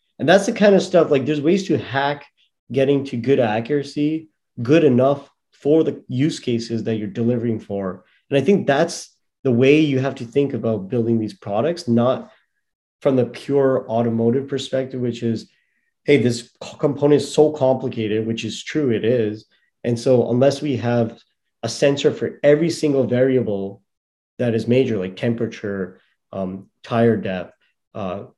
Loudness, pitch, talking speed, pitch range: -20 LUFS, 125 Hz, 165 wpm, 115-140 Hz